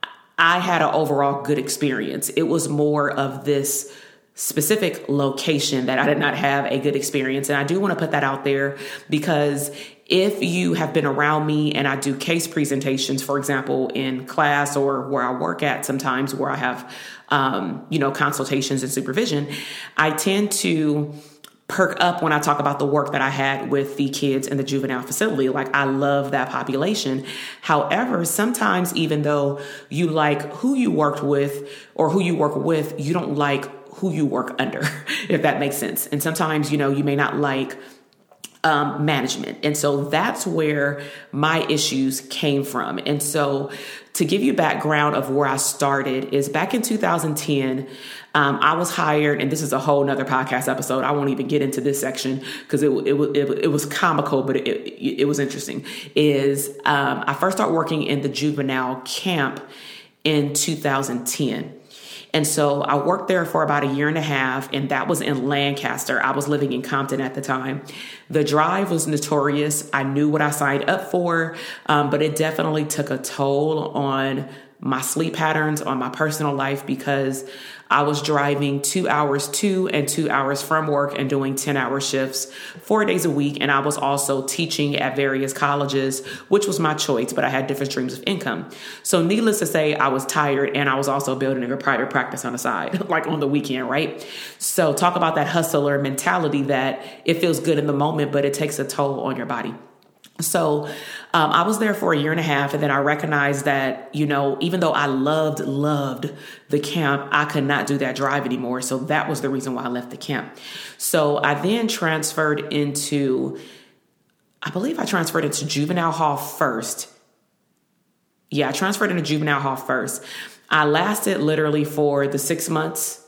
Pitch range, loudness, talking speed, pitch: 135-155 Hz, -21 LUFS, 190 wpm, 145 Hz